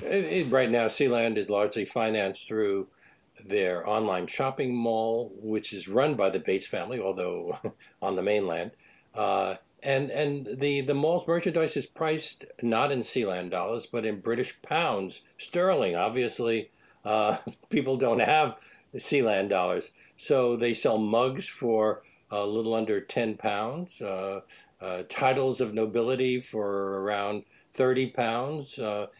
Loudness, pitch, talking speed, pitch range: -28 LUFS, 115 Hz, 140 wpm, 105-130 Hz